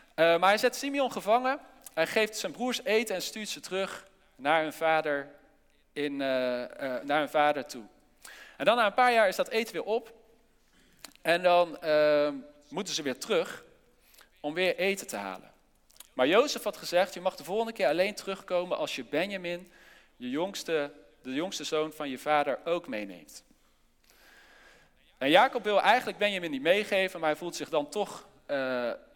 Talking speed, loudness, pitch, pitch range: 175 wpm, -29 LUFS, 185 Hz, 155-225 Hz